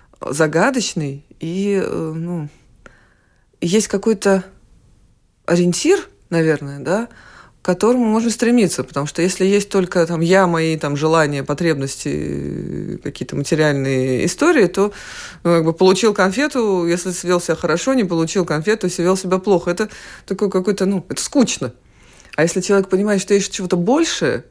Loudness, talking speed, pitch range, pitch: -18 LUFS, 140 wpm, 160-200 Hz, 180 Hz